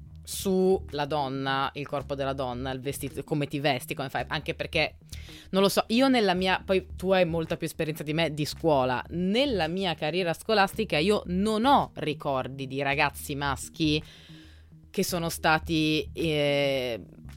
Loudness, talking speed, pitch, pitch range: -27 LUFS, 160 wpm, 150 Hz, 135-180 Hz